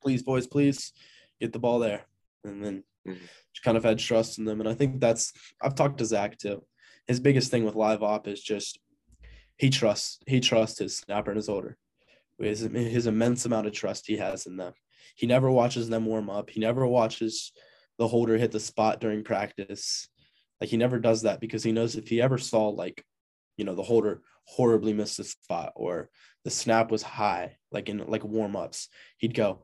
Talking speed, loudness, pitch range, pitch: 200 wpm, -28 LUFS, 105-120 Hz, 110 Hz